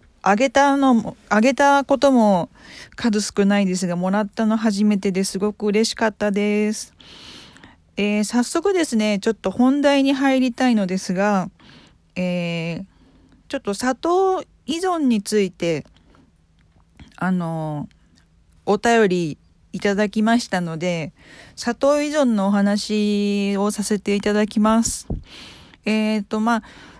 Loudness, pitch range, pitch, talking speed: -20 LUFS, 190-235 Hz, 210 Hz, 245 characters per minute